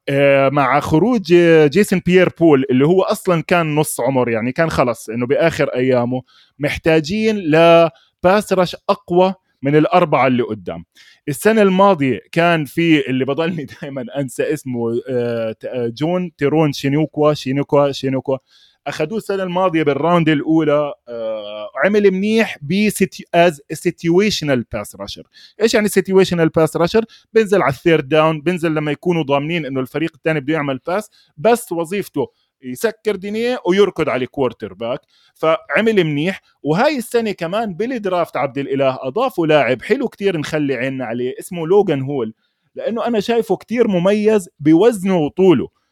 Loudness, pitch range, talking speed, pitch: -16 LUFS, 140-190 Hz, 135 wpm, 160 Hz